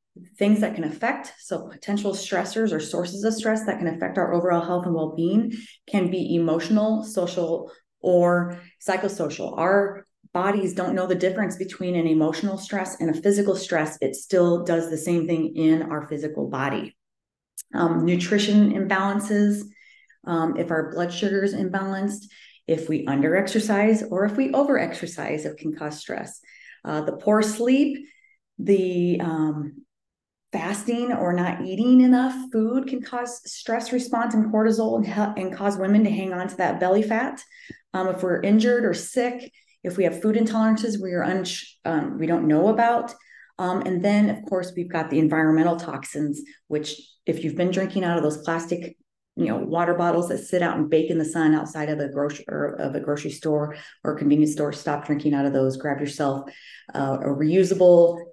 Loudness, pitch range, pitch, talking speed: -23 LUFS, 160-210 Hz, 180 Hz, 180 wpm